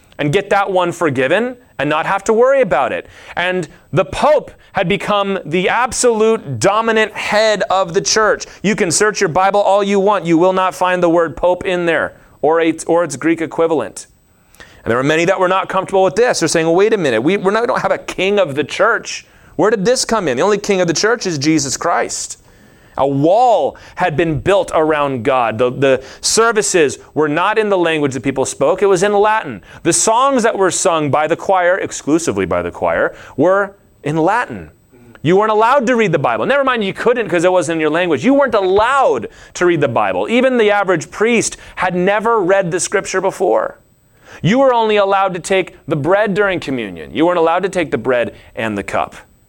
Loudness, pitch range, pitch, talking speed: -14 LUFS, 165-210 Hz, 185 Hz, 215 wpm